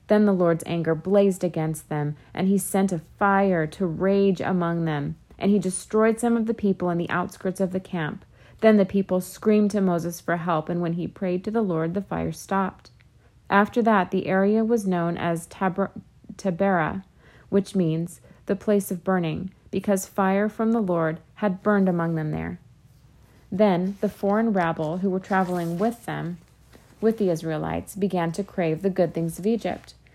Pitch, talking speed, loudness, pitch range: 190 Hz, 185 wpm, -24 LUFS, 170-200 Hz